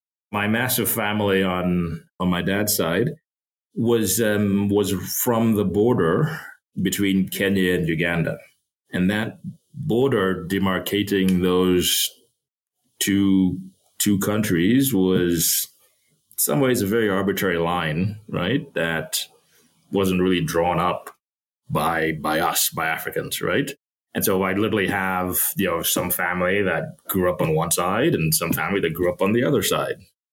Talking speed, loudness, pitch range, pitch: 140 wpm, -21 LUFS, 90-100 Hz, 95 Hz